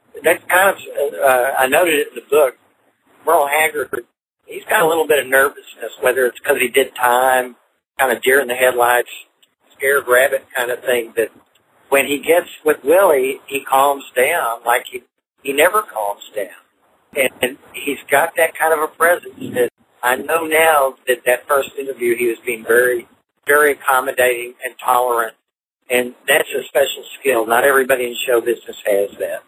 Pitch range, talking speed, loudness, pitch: 125-170 Hz, 180 wpm, -16 LUFS, 135 Hz